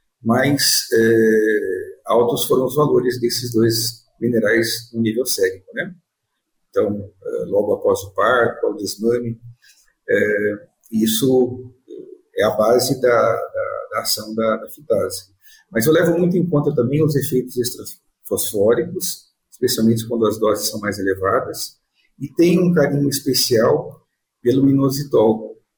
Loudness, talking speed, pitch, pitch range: -18 LUFS, 135 wpm, 130 Hz, 115-180 Hz